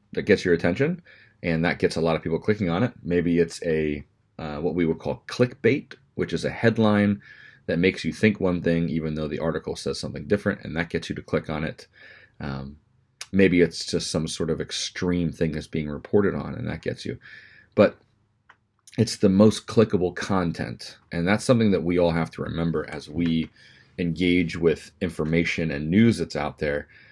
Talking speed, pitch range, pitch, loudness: 200 wpm, 80-100 Hz, 85 Hz, -24 LUFS